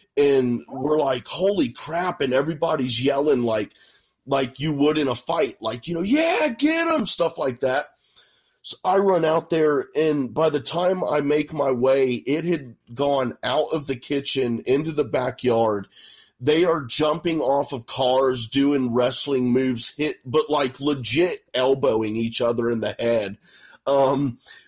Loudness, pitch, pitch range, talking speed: -22 LUFS, 140 Hz, 125-160 Hz, 165 wpm